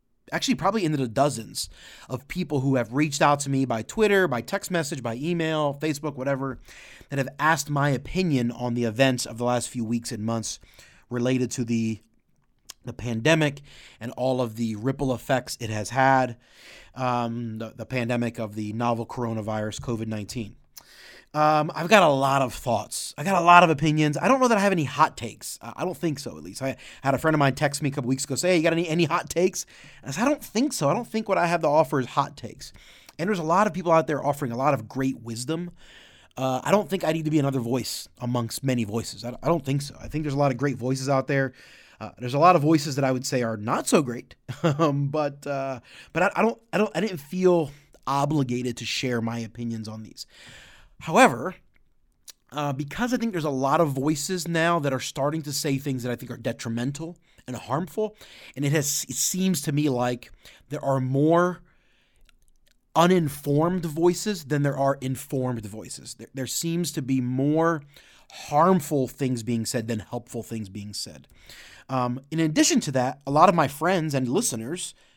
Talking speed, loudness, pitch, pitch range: 215 wpm, -25 LUFS, 140 Hz, 125-160 Hz